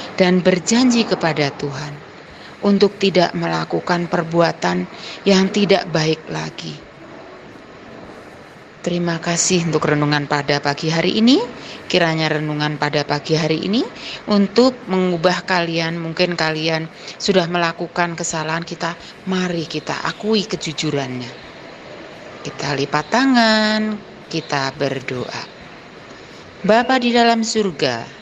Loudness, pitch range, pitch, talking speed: -18 LUFS, 155-195 Hz, 170 Hz, 100 wpm